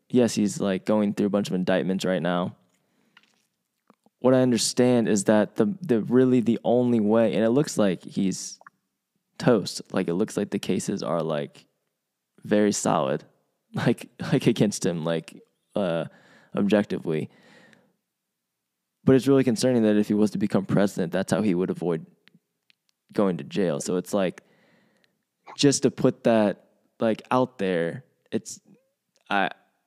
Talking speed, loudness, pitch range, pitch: 155 wpm, -24 LUFS, 100-125 Hz, 110 Hz